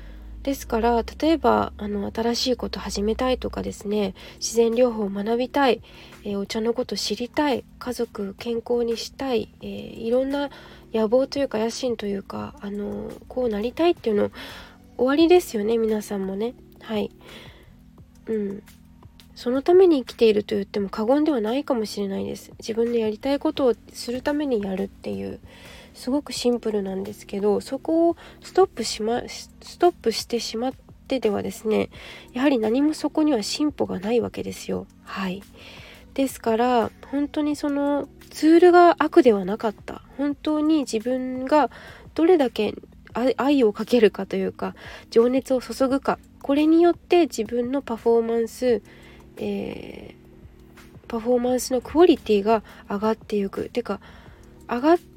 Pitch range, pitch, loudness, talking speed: 210-270 Hz, 235 Hz, -23 LUFS, 325 characters per minute